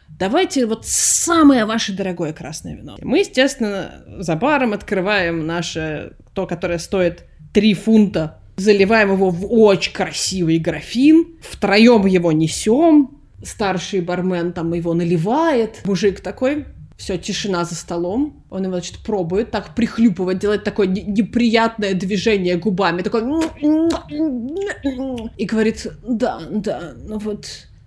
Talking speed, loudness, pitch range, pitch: 125 wpm, -18 LUFS, 185-235 Hz, 205 Hz